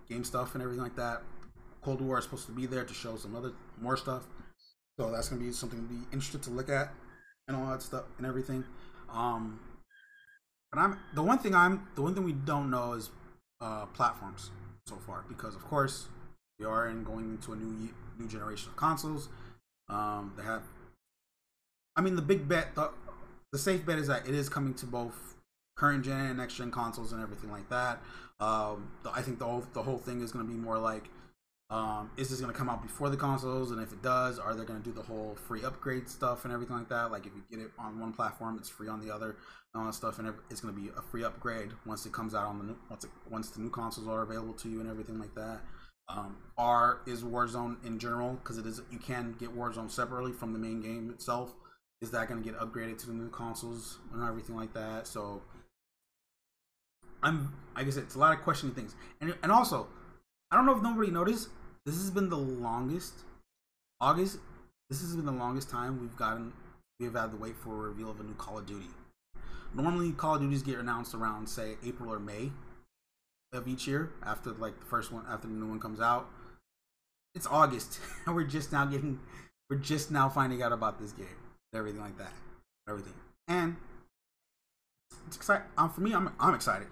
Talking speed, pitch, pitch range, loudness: 220 wpm, 120 Hz, 110-130 Hz, -35 LUFS